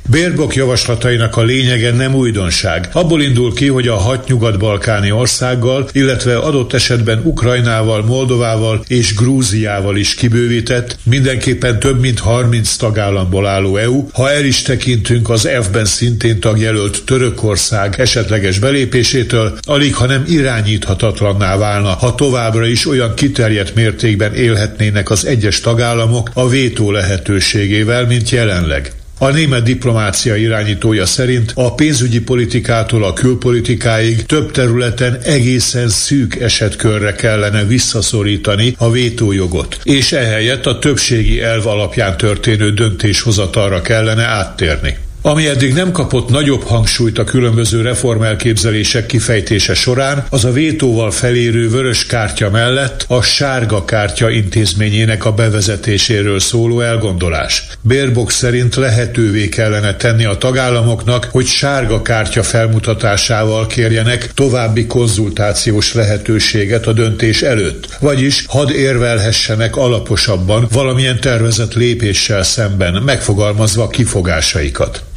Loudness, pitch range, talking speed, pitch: -12 LUFS, 105-125 Hz, 115 wpm, 115 Hz